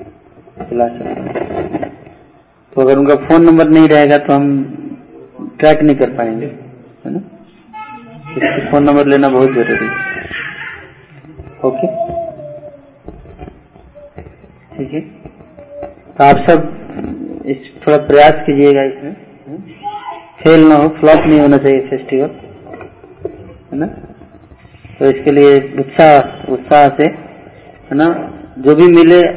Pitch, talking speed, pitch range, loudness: 150 Hz, 115 wpm, 140-170 Hz, -10 LUFS